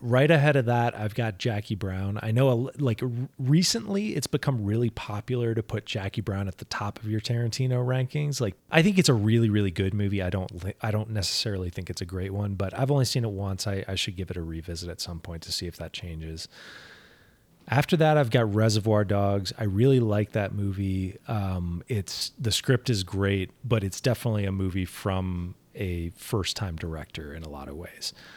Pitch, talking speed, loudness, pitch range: 105 Hz, 215 wpm, -27 LUFS, 95-120 Hz